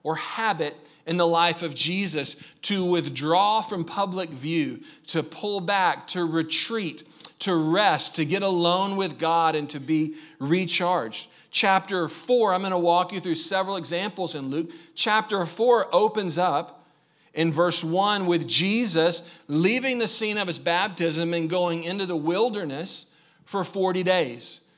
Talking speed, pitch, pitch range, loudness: 150 wpm, 175 Hz, 160-195 Hz, -23 LUFS